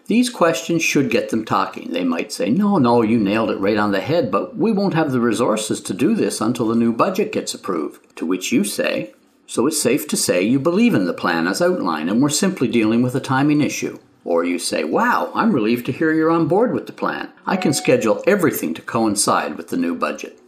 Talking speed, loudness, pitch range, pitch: 235 wpm, -19 LUFS, 120-195 Hz, 150 Hz